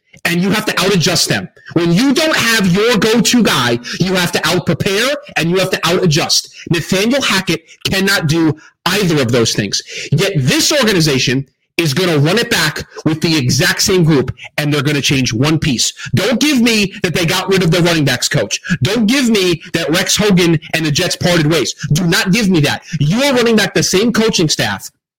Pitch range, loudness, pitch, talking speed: 155-200 Hz, -13 LUFS, 175 Hz, 215 wpm